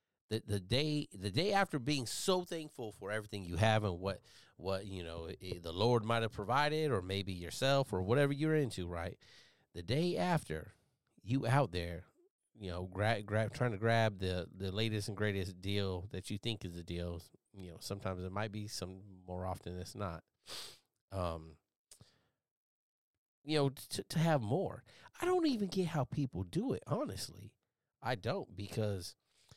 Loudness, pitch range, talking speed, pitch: -37 LUFS, 95-135 Hz, 175 wpm, 105 Hz